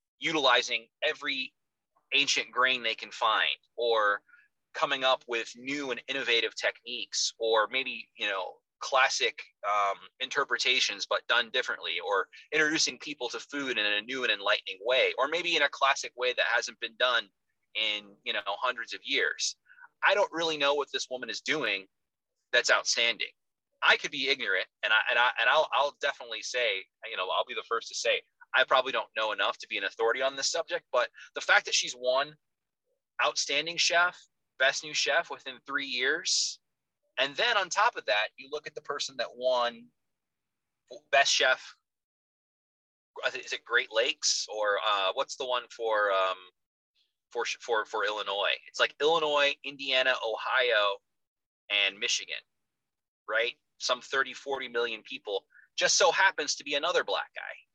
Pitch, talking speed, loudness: 155 Hz, 165 wpm, -28 LUFS